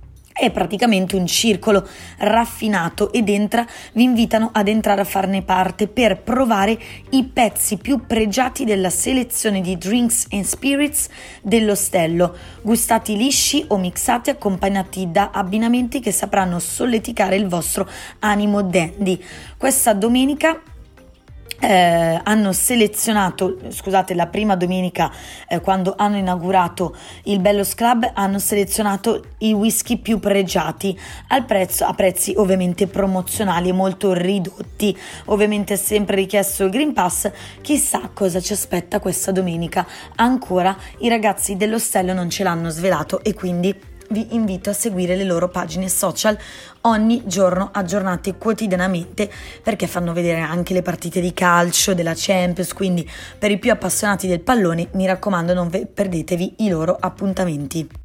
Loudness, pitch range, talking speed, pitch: -18 LUFS, 185-220 Hz, 135 wpm, 200 Hz